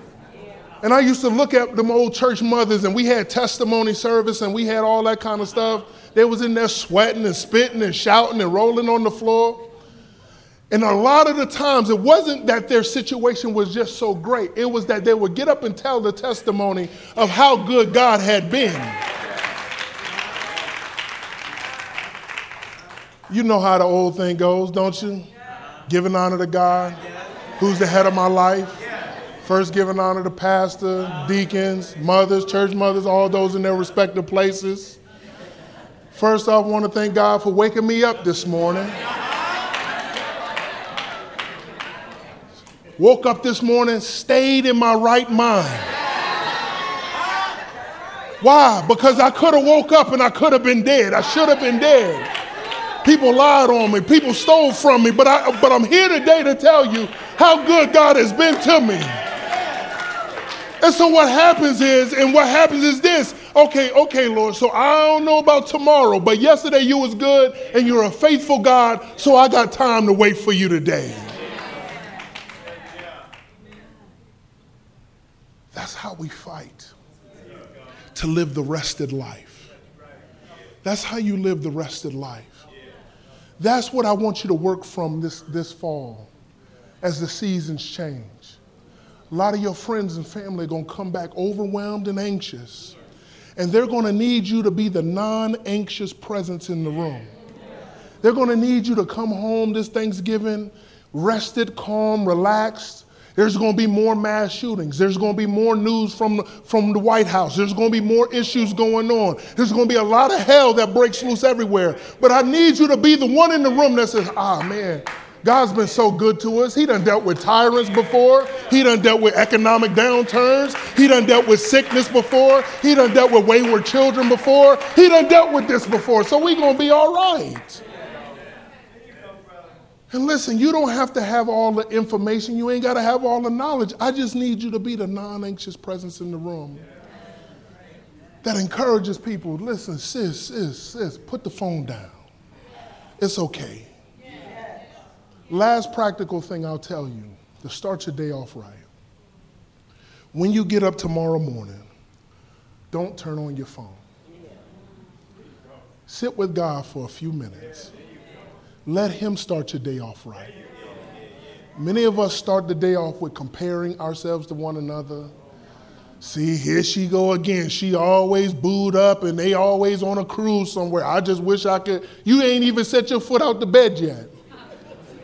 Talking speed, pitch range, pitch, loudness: 170 wpm, 185-245 Hz, 215 Hz, -17 LUFS